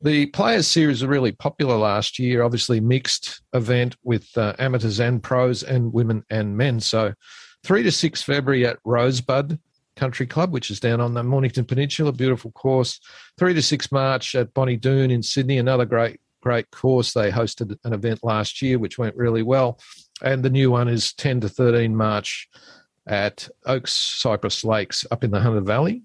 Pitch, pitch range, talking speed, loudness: 125 Hz, 115-135 Hz, 180 wpm, -21 LUFS